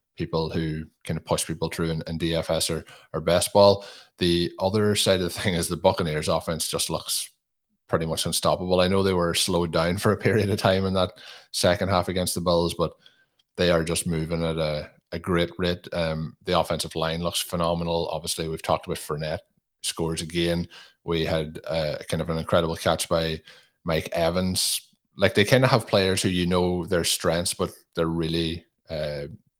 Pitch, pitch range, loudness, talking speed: 85 Hz, 80-95 Hz, -25 LUFS, 195 wpm